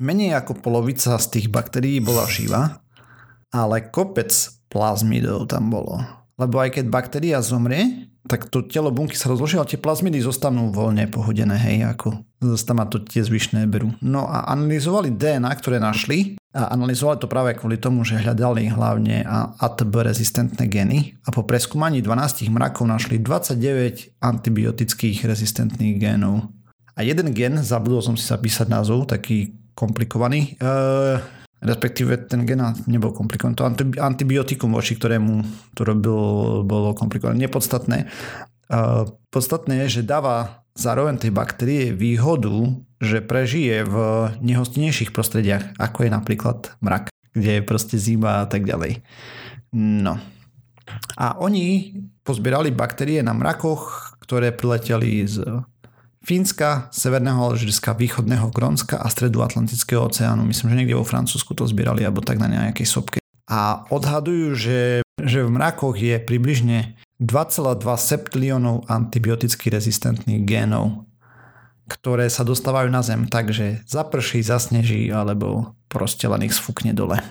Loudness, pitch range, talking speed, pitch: -21 LUFS, 110-130 Hz, 135 wpm, 120 Hz